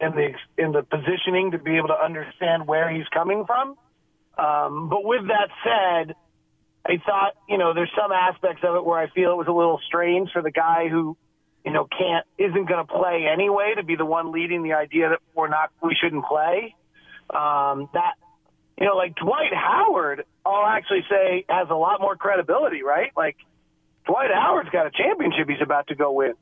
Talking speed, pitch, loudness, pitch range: 200 wpm, 170 Hz, -22 LUFS, 160-195 Hz